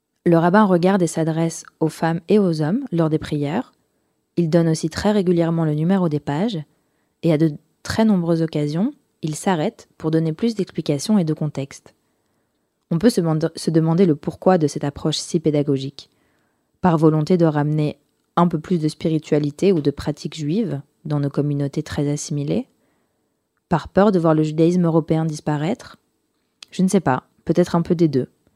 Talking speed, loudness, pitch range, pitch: 175 wpm, -20 LUFS, 150-175 Hz, 160 Hz